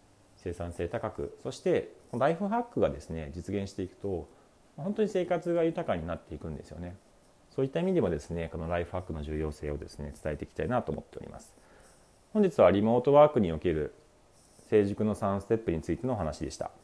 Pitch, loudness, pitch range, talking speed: 95 Hz, -30 LUFS, 80-130 Hz, 315 characters per minute